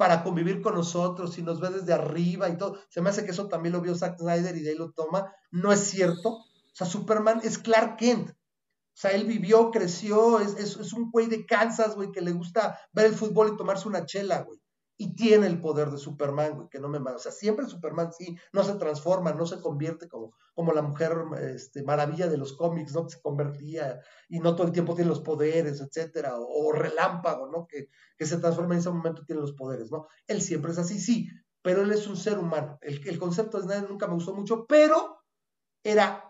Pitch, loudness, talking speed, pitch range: 180 Hz, -27 LUFS, 235 wpm, 160-205 Hz